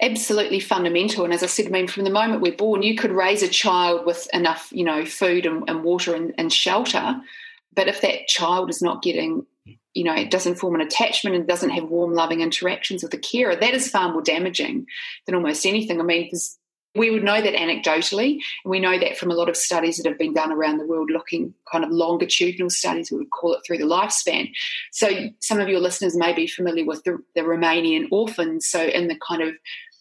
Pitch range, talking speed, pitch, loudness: 170-215 Hz, 225 wpm, 180 Hz, -21 LUFS